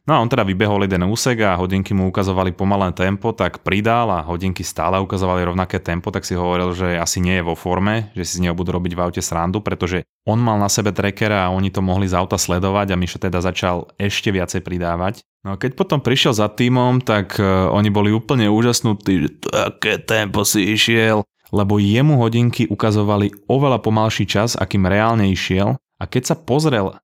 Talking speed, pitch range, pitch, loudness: 200 wpm, 95-110 Hz, 100 Hz, -18 LUFS